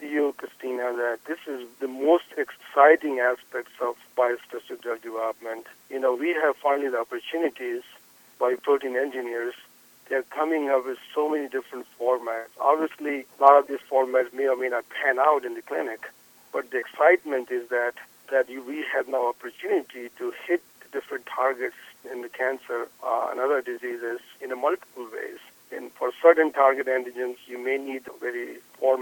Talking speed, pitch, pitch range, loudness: 170 wpm, 135 Hz, 125-160 Hz, -26 LUFS